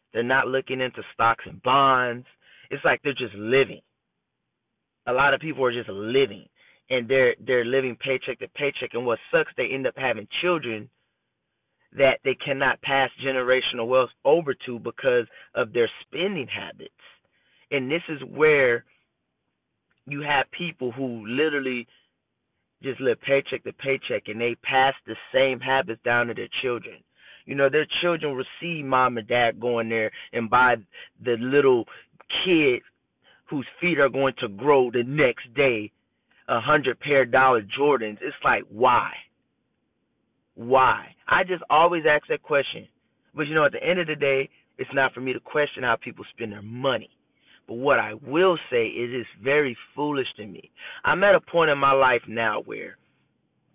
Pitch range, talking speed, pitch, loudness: 120-150 Hz, 170 wpm, 135 Hz, -23 LUFS